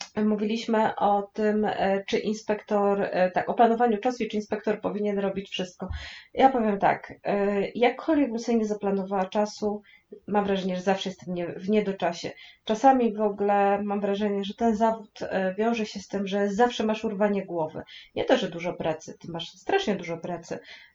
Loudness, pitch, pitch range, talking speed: -26 LUFS, 205 Hz, 195-220 Hz, 165 wpm